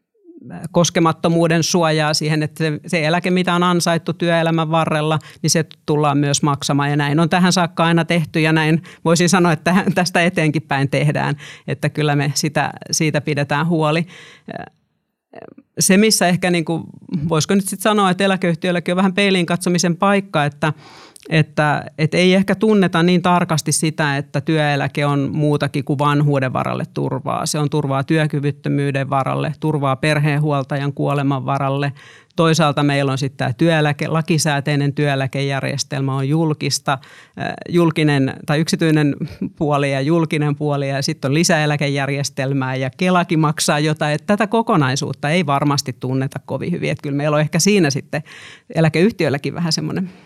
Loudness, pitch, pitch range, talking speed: -17 LUFS, 155 Hz, 145-175 Hz, 145 wpm